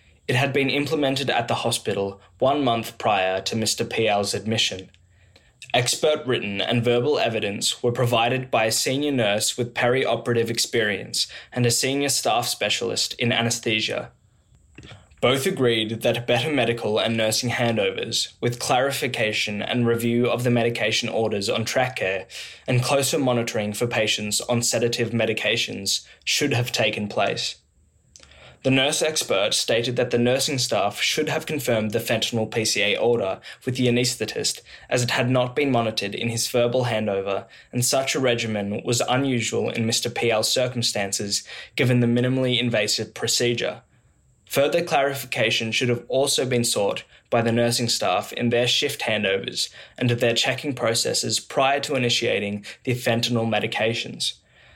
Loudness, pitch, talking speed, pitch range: -22 LUFS, 120 Hz, 145 wpm, 110-125 Hz